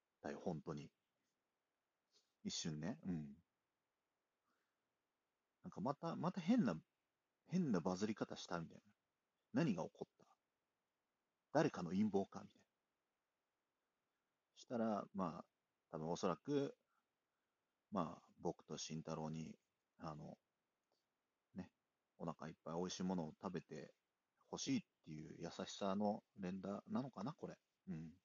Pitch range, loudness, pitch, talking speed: 80-110 Hz, -46 LUFS, 95 Hz, 220 characters per minute